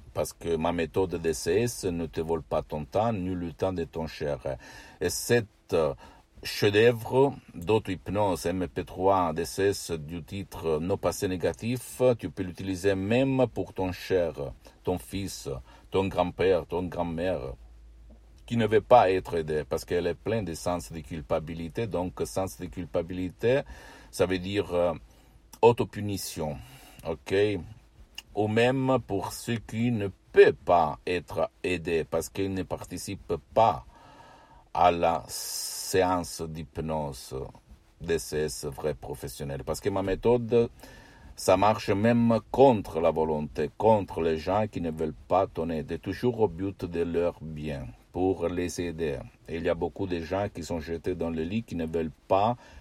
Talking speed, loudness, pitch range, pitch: 150 wpm, -28 LUFS, 80-105 Hz, 90 Hz